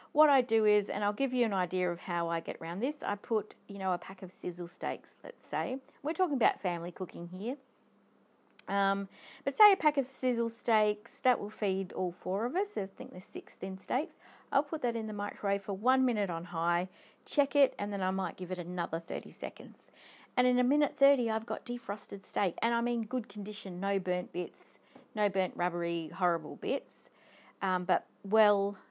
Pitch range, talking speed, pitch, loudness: 185-250 Hz, 210 wpm, 205 Hz, -32 LUFS